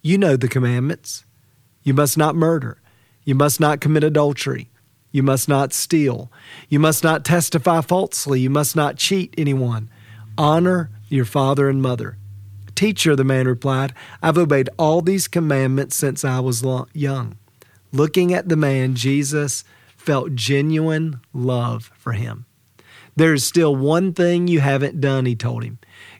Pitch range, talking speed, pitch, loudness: 125-155 Hz, 150 wpm, 140 Hz, -19 LUFS